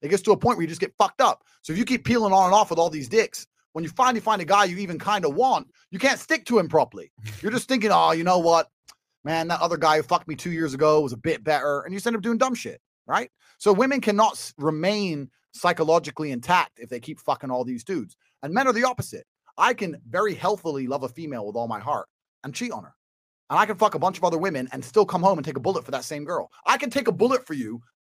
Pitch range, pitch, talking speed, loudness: 155-220 Hz, 175 Hz, 280 wpm, -23 LUFS